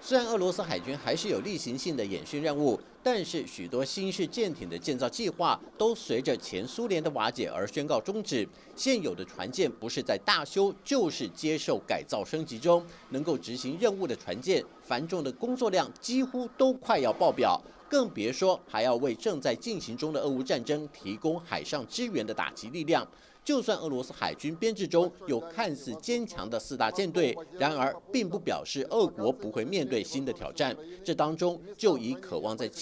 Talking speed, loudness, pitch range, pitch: 285 characters per minute, -31 LUFS, 155-240 Hz, 190 Hz